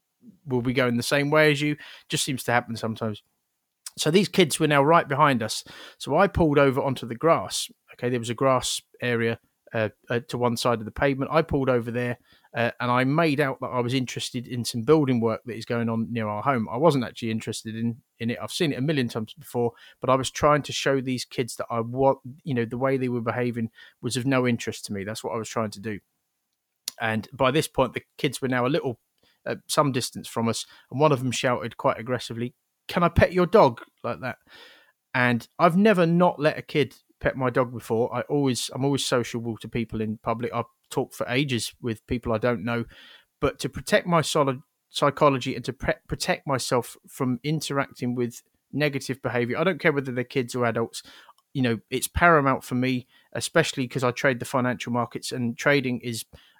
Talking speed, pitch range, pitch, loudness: 220 wpm, 115-140 Hz, 125 Hz, -25 LUFS